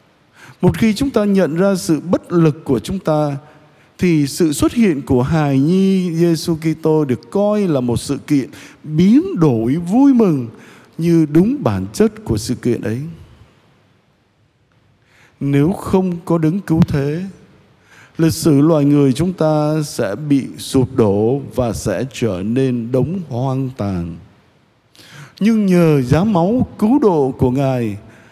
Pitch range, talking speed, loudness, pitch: 125-175 Hz, 150 wpm, -16 LUFS, 150 Hz